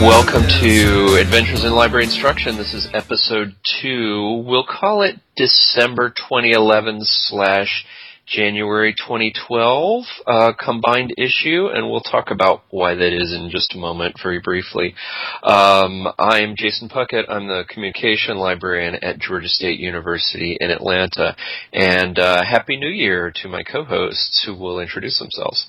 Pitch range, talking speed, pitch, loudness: 90-115 Hz, 140 wpm, 105 Hz, -16 LUFS